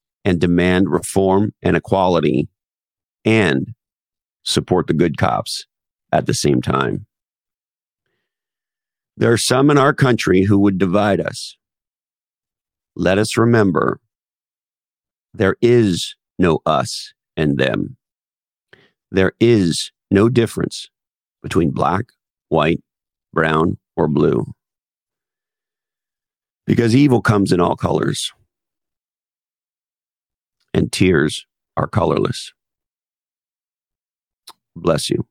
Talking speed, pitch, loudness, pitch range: 95 wpm, 105 Hz, -17 LUFS, 90-120 Hz